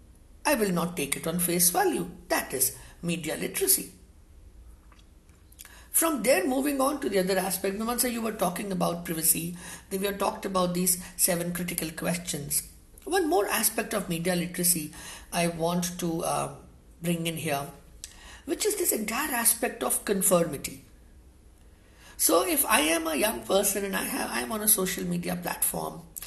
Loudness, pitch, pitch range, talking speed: -26 LUFS, 175 Hz, 150-215 Hz, 170 wpm